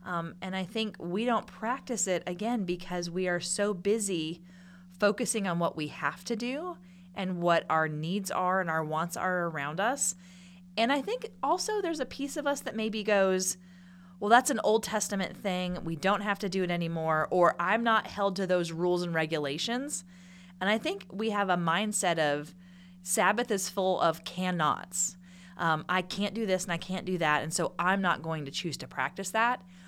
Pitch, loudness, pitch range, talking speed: 185 Hz, -30 LUFS, 175-210 Hz, 200 wpm